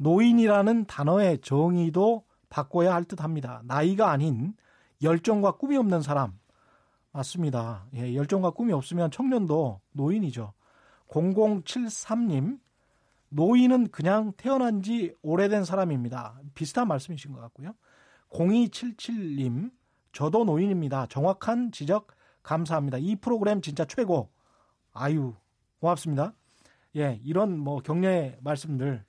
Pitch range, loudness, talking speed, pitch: 140-210 Hz, -27 LUFS, 260 characters per minute, 170 Hz